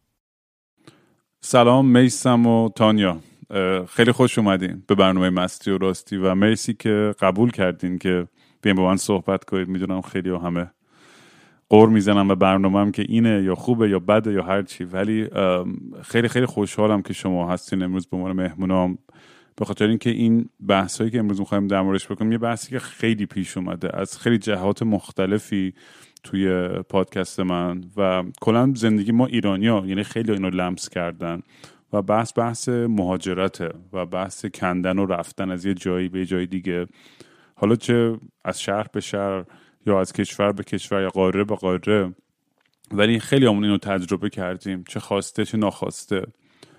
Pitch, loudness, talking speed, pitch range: 100 Hz, -21 LUFS, 160 wpm, 95-110 Hz